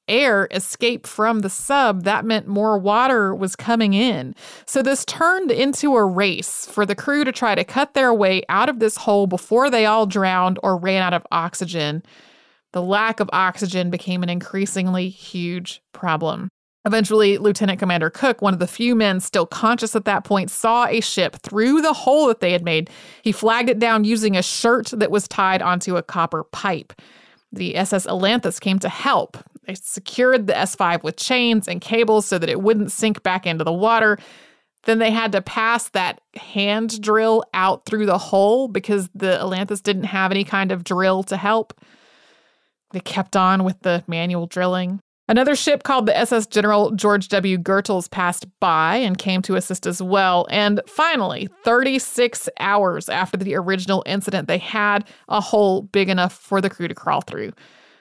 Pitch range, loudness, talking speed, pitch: 185-225 Hz, -19 LUFS, 185 wpm, 200 Hz